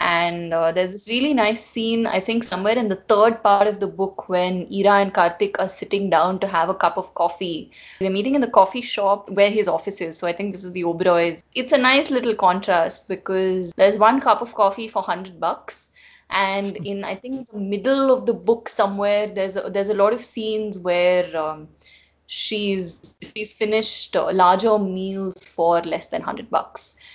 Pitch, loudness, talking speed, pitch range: 200 Hz, -20 LUFS, 200 wpm, 185-220 Hz